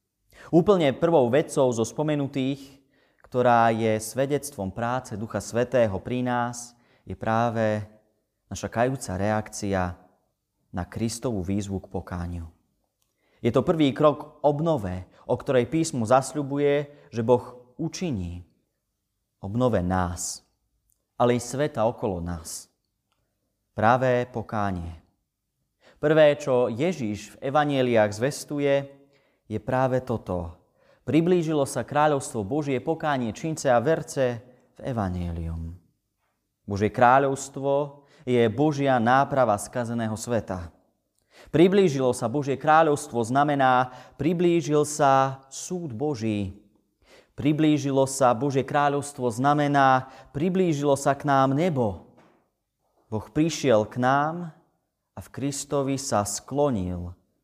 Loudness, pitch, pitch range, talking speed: -24 LUFS, 125 Hz, 105-145 Hz, 100 wpm